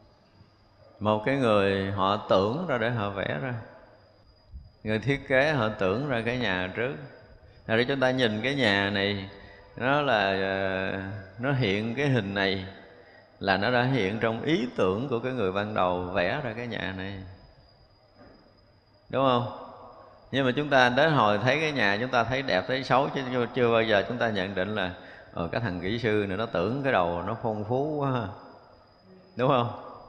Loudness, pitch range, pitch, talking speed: -26 LUFS, 95-125 Hz, 105 Hz, 185 wpm